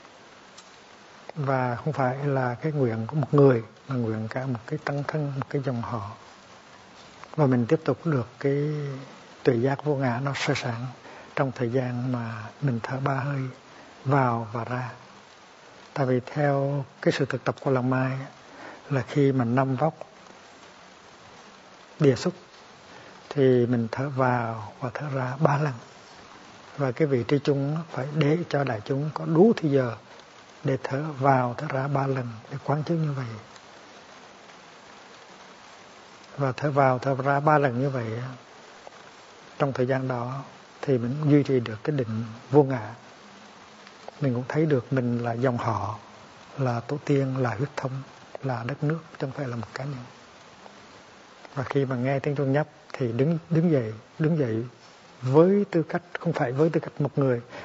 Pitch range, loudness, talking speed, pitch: 125-145 Hz, -26 LUFS, 175 wpm, 135 Hz